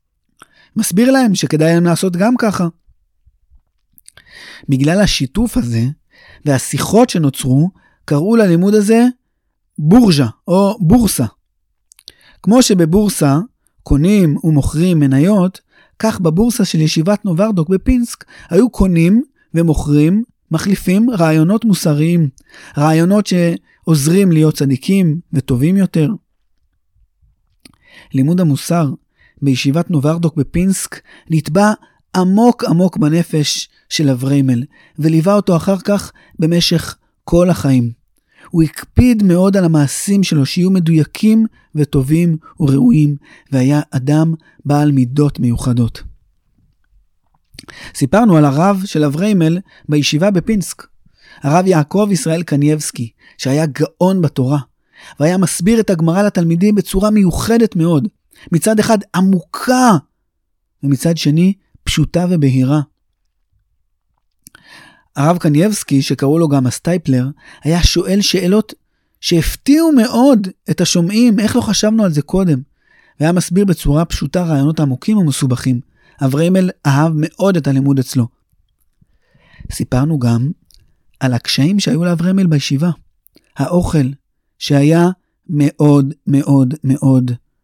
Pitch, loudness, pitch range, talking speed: 165 Hz, -14 LUFS, 140-190 Hz, 100 wpm